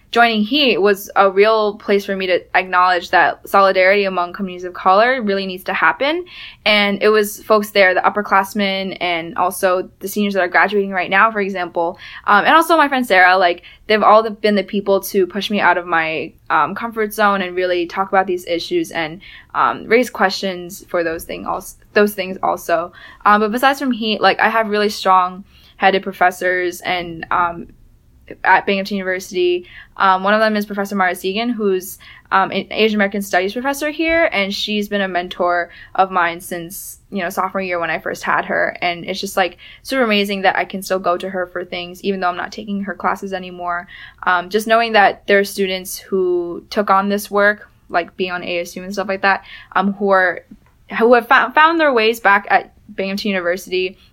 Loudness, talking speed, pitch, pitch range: -16 LUFS, 200 wpm, 195 Hz, 180-210 Hz